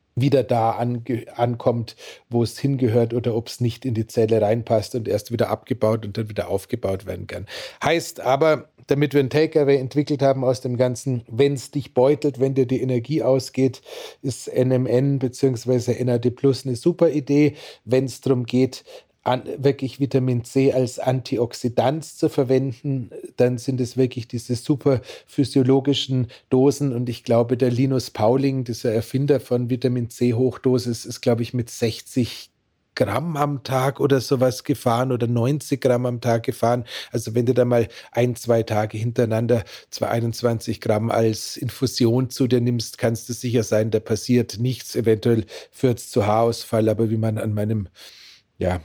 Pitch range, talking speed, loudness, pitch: 115-135 Hz, 170 wpm, -22 LUFS, 125 Hz